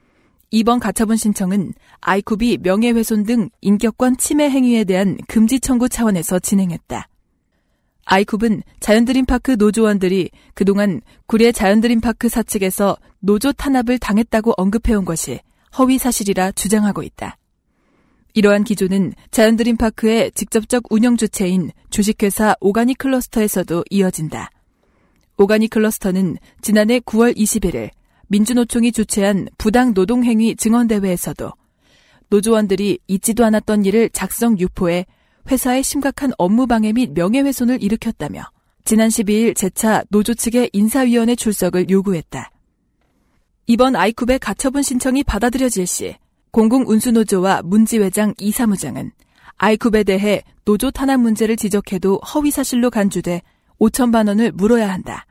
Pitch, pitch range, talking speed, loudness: 220 Hz, 195-235 Hz, 325 characters per minute, -16 LUFS